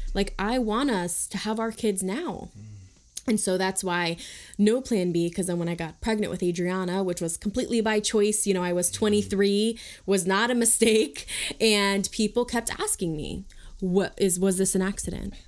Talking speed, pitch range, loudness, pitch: 190 wpm, 180-220 Hz, -25 LUFS, 200 Hz